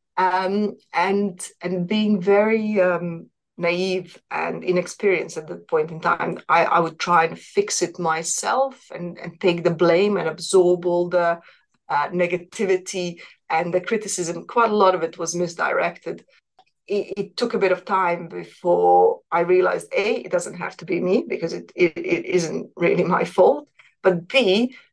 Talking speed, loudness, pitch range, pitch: 170 wpm, -21 LUFS, 175-210 Hz, 185 Hz